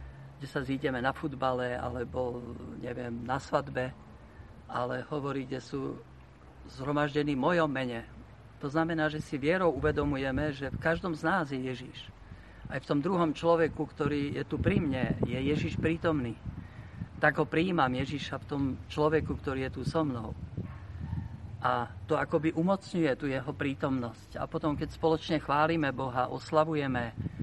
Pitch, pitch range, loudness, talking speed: 135 Hz, 120-155 Hz, -32 LUFS, 150 wpm